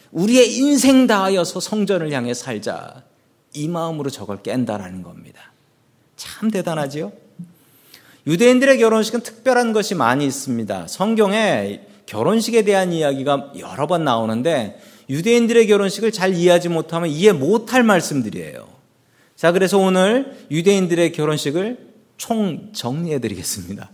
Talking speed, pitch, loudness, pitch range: 320 characters per minute, 175 Hz, -18 LUFS, 140-215 Hz